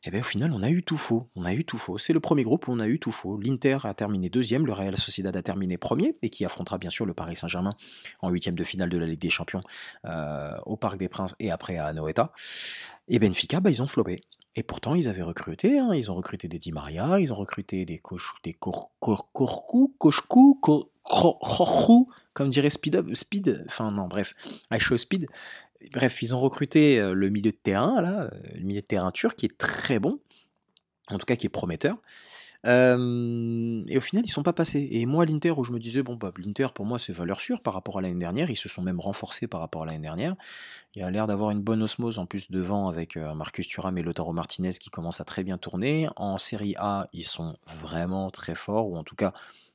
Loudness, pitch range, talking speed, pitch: -26 LUFS, 90-135 Hz, 235 wpm, 105 Hz